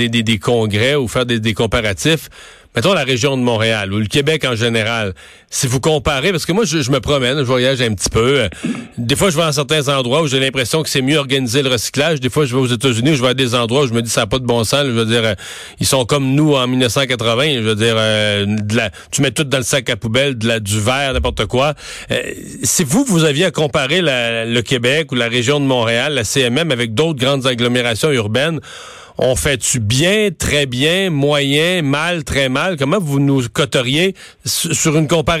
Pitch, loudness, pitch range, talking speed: 135 Hz, -15 LUFS, 120-150 Hz, 235 wpm